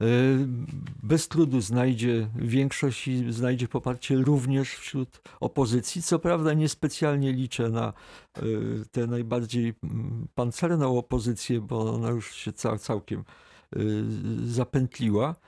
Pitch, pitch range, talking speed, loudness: 125 Hz, 115-135 Hz, 95 wpm, -27 LUFS